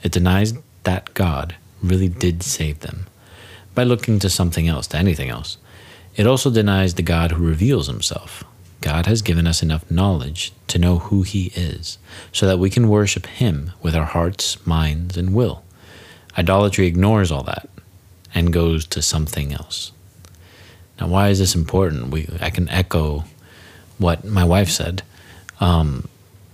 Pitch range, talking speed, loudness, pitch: 85-100 Hz, 160 wpm, -19 LUFS, 90 Hz